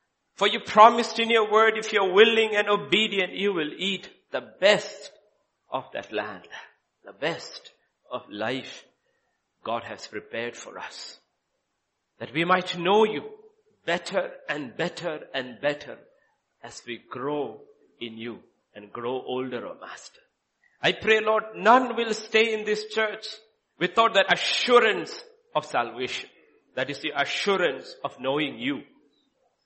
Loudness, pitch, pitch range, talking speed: -24 LUFS, 215 Hz, 180-225 Hz, 145 wpm